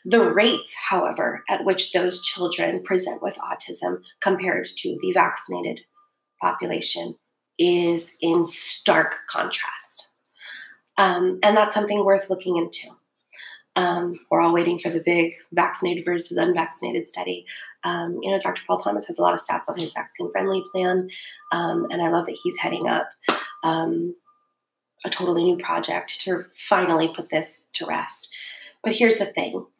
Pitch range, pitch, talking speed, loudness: 170-195 Hz, 180 Hz, 155 wpm, -22 LUFS